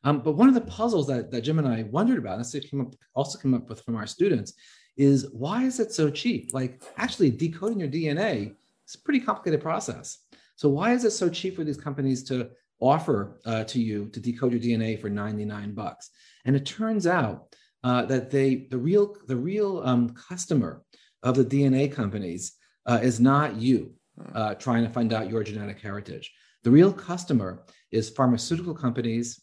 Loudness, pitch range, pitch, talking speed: -26 LUFS, 120-165 Hz, 130 Hz, 195 wpm